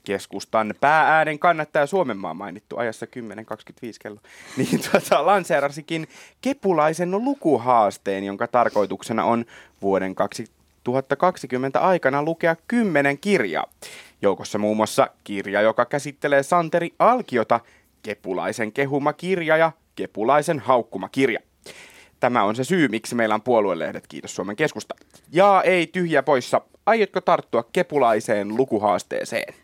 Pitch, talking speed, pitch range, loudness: 140 Hz, 110 wpm, 110-175 Hz, -21 LUFS